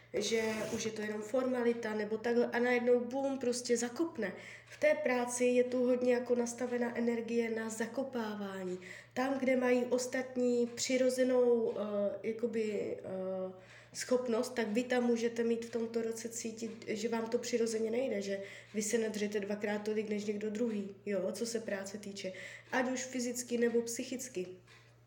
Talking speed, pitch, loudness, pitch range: 160 wpm, 235 Hz, -35 LUFS, 215-245 Hz